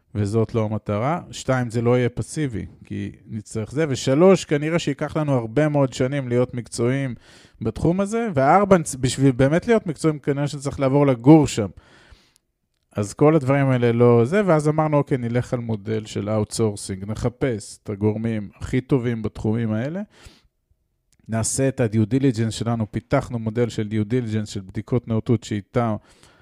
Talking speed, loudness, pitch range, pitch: 150 wpm, -21 LUFS, 110-140 Hz, 120 Hz